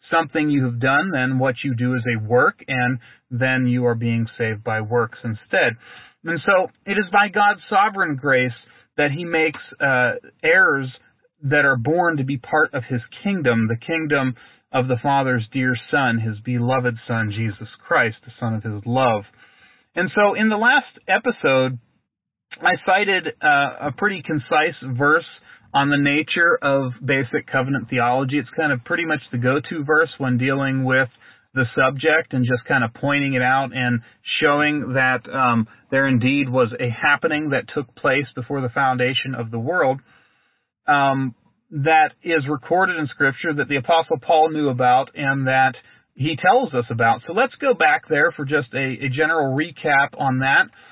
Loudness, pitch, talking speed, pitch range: -20 LUFS, 135 Hz, 175 wpm, 125-155 Hz